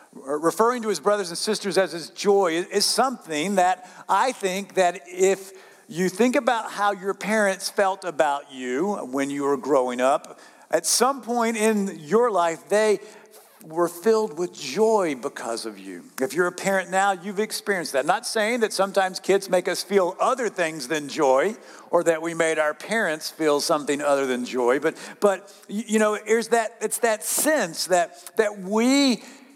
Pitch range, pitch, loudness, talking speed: 165-215 Hz, 195 Hz, -23 LUFS, 180 wpm